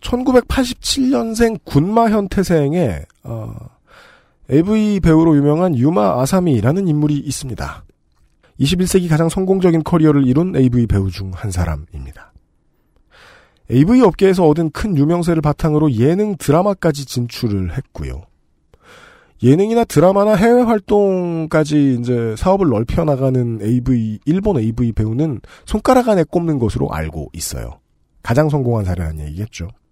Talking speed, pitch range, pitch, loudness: 295 characters per minute, 115-185 Hz, 150 Hz, -15 LUFS